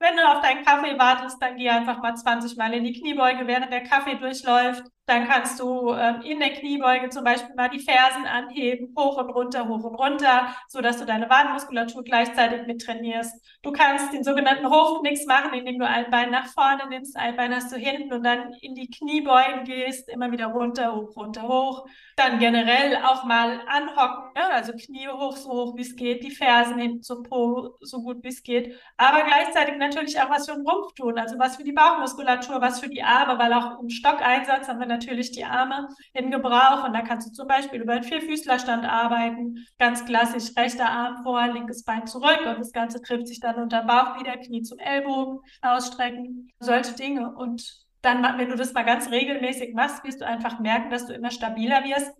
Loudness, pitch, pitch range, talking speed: -23 LUFS, 250 Hz, 240-270 Hz, 210 wpm